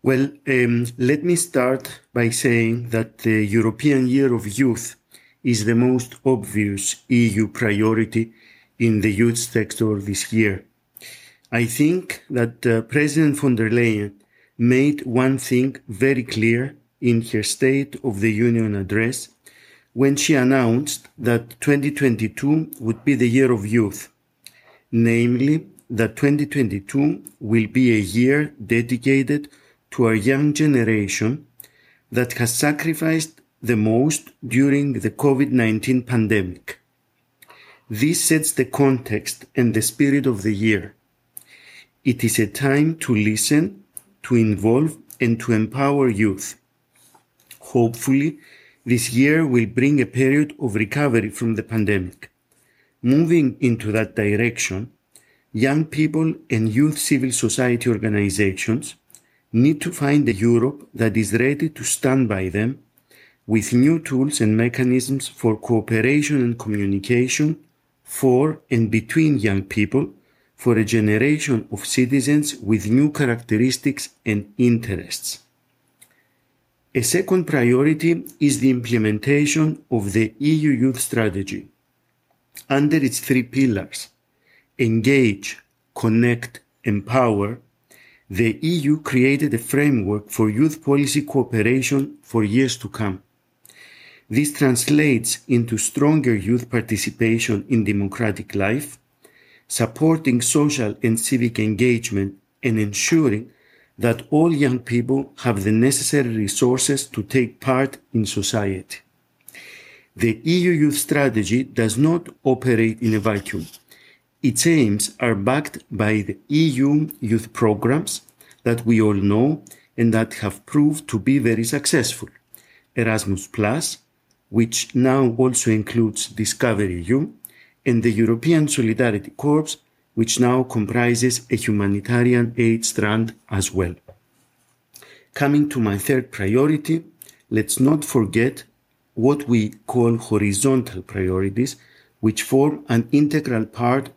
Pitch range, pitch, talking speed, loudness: 110-140 Hz, 120 Hz, 120 wpm, -20 LUFS